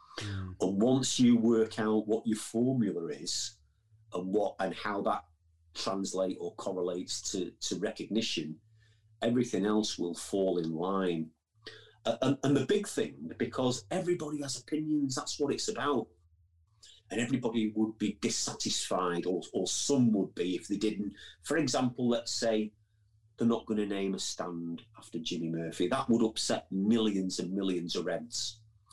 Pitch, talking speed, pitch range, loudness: 110 Hz, 155 wpm, 95-115 Hz, -32 LUFS